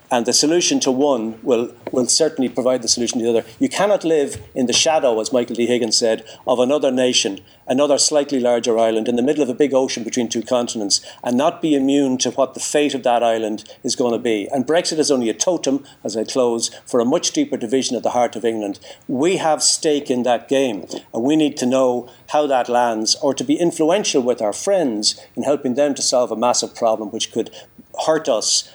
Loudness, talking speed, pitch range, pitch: -18 LUFS, 225 wpm, 115-145 Hz, 125 Hz